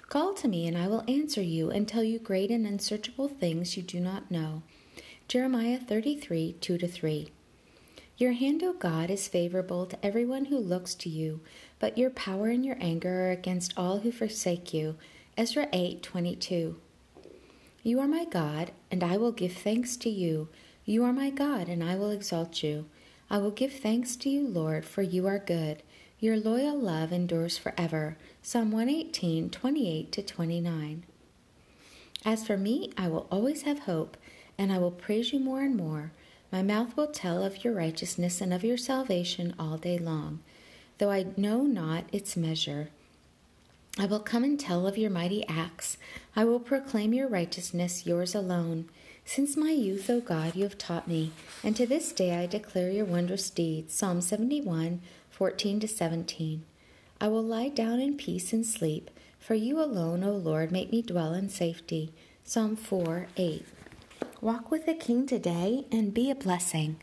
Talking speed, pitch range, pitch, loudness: 180 wpm, 170-235 Hz, 195 Hz, -31 LUFS